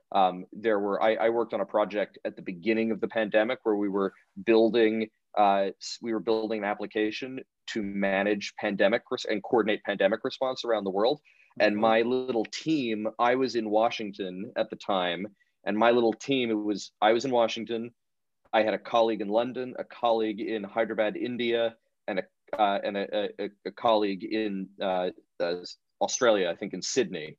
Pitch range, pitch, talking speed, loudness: 105-115 Hz, 110 Hz, 185 wpm, -28 LUFS